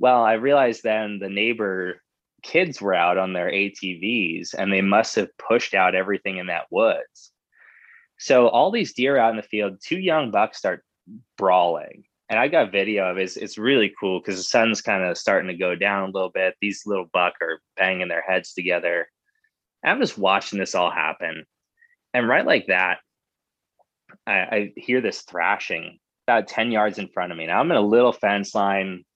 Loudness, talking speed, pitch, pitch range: -22 LUFS, 195 wpm, 100 Hz, 95-120 Hz